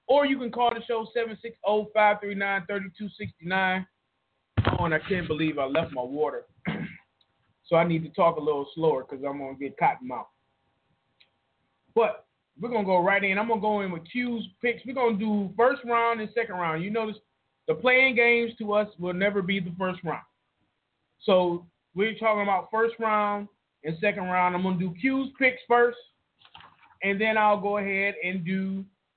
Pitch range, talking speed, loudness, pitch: 180-230 Hz, 190 wpm, -26 LUFS, 205 Hz